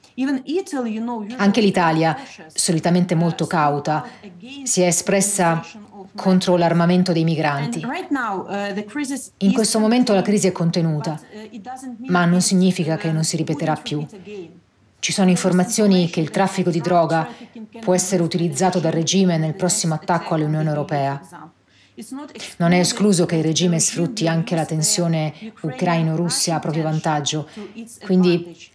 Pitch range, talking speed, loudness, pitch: 165-205 Hz, 125 wpm, -19 LUFS, 180 Hz